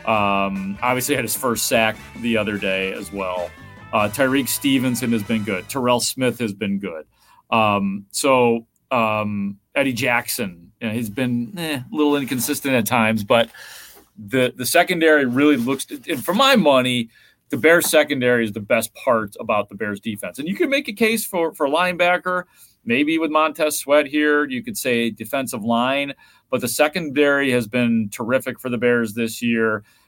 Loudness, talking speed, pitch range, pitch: -20 LUFS, 180 wpm, 110-150 Hz, 125 Hz